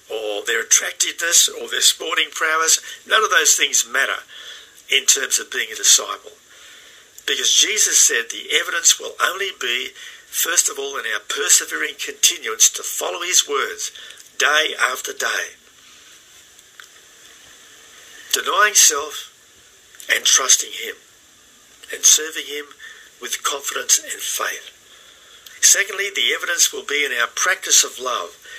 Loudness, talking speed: -16 LUFS, 130 wpm